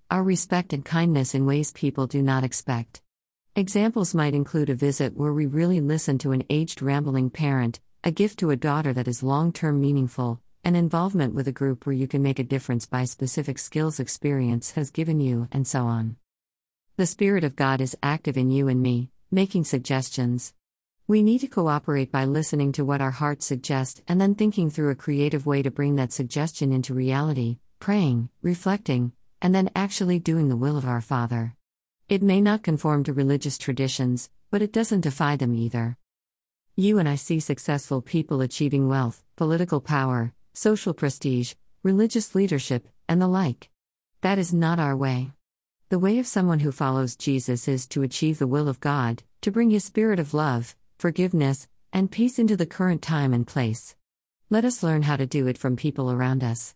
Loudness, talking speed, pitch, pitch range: -24 LUFS, 185 wpm, 140 Hz, 130-165 Hz